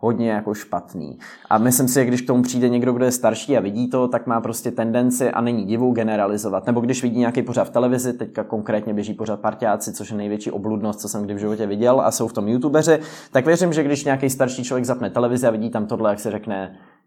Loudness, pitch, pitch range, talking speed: -20 LUFS, 120 Hz, 110-125 Hz, 245 wpm